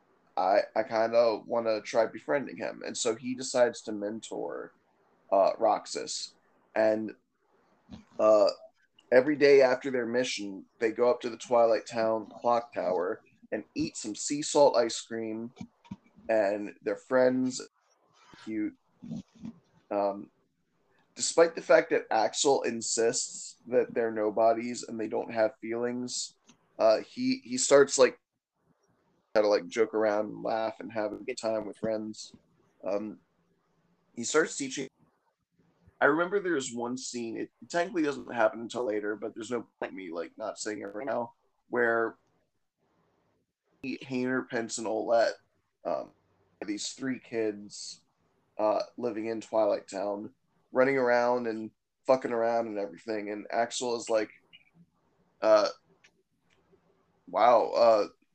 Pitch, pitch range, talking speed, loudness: 115 Hz, 110-130 Hz, 140 wpm, -29 LUFS